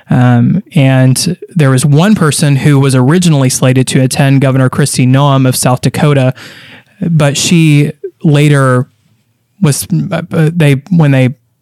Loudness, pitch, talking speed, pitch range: -9 LUFS, 140 Hz, 125 wpm, 130-160 Hz